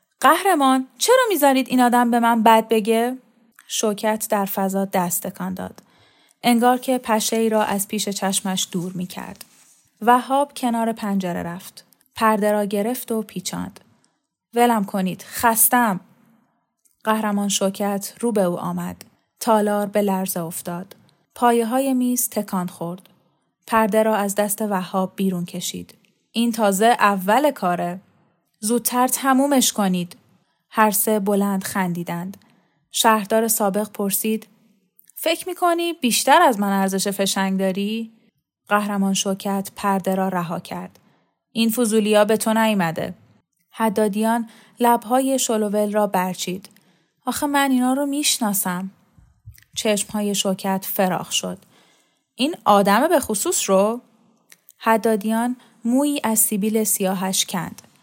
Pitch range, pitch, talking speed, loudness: 195-235 Hz, 210 Hz, 120 wpm, -20 LUFS